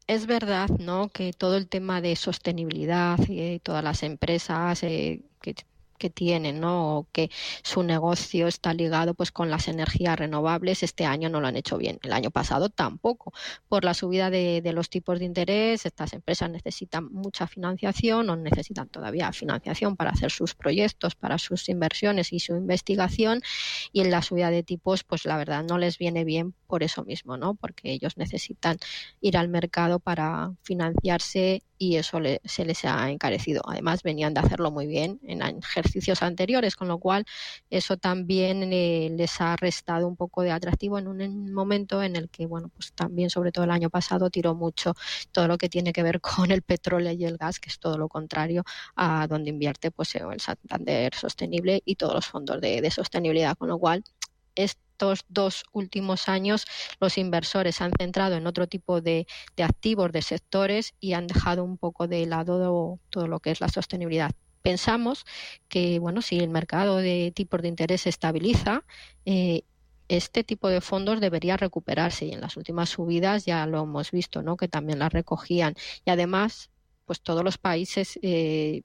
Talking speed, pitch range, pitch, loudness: 185 wpm, 165-190 Hz, 175 Hz, -27 LUFS